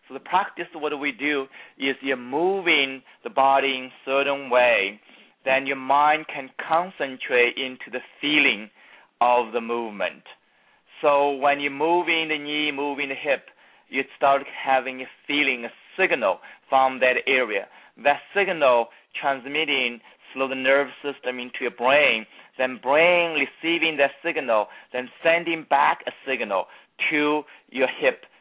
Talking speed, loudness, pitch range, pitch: 145 wpm, -23 LUFS, 130-150 Hz, 140 Hz